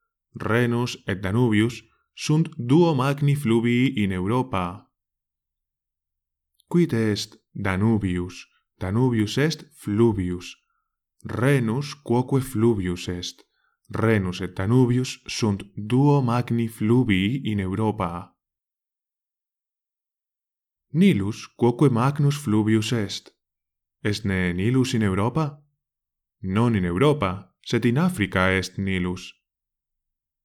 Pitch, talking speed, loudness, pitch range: 110 Hz, 90 wpm, -23 LUFS, 95-130 Hz